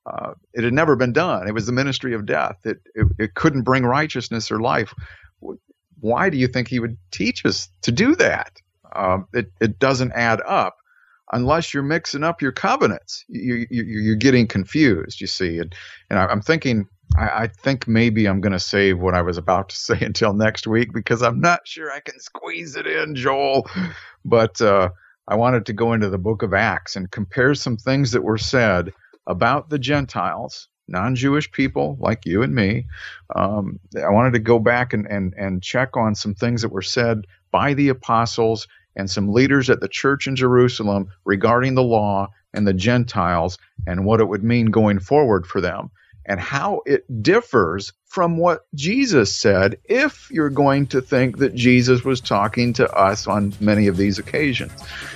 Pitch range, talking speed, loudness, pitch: 100-130 Hz, 190 wpm, -19 LUFS, 115 Hz